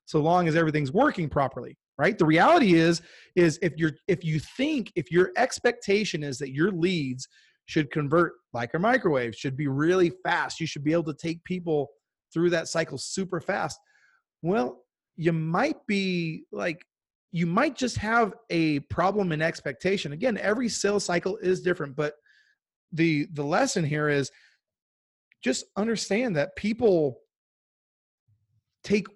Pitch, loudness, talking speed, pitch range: 170 Hz, -26 LUFS, 150 wpm, 150-195 Hz